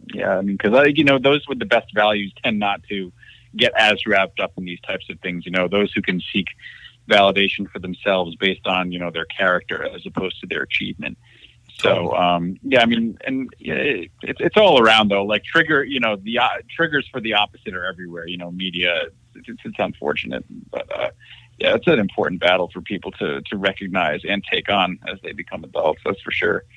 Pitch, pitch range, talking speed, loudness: 100 Hz, 90-110 Hz, 215 wpm, -19 LUFS